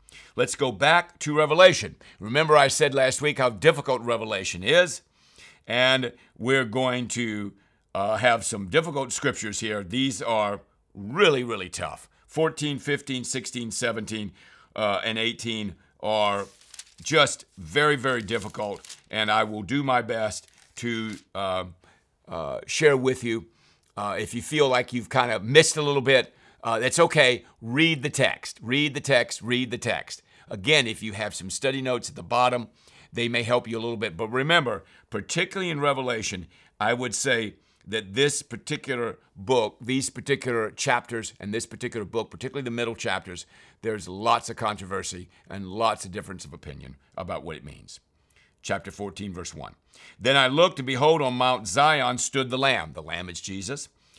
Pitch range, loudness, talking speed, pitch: 105-135 Hz, -24 LUFS, 165 wpm, 120 Hz